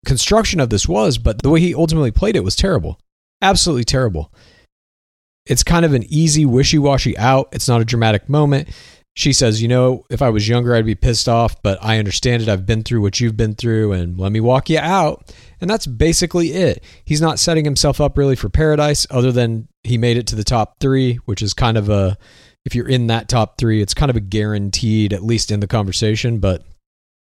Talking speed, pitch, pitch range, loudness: 220 wpm, 120 Hz, 105-140 Hz, -16 LUFS